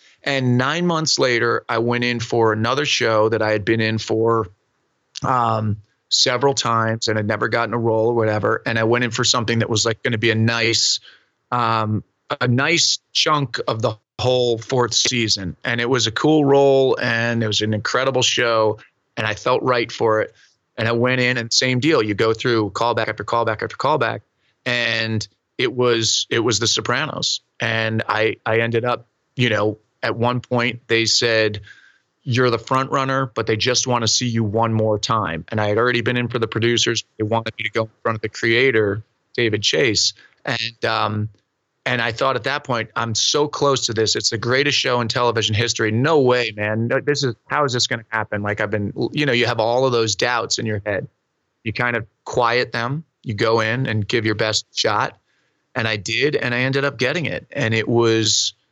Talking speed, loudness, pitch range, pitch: 210 wpm, -19 LUFS, 110-125 Hz, 115 Hz